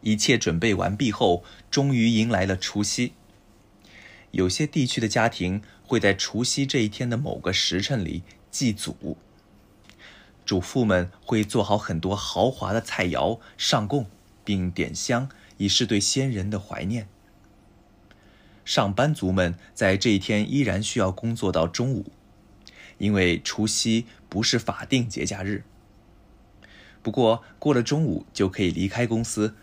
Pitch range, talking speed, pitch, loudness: 100-115 Hz, 210 characters per minute, 105 Hz, -24 LUFS